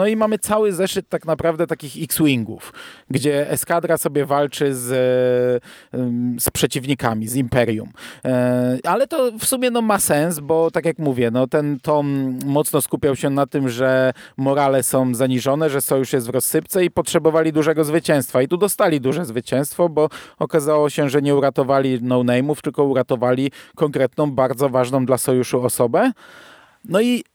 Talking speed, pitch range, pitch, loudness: 160 wpm, 130-160 Hz, 145 Hz, -19 LUFS